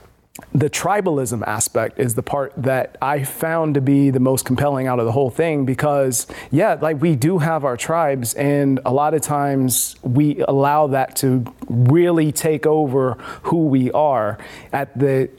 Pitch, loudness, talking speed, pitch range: 140 Hz, -18 LUFS, 170 wpm, 130-150 Hz